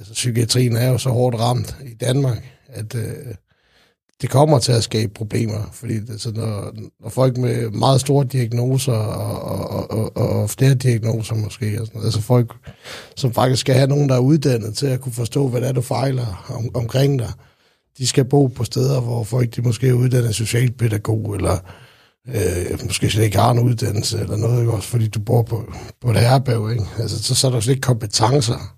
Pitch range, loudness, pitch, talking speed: 110-130 Hz, -19 LUFS, 120 Hz, 200 wpm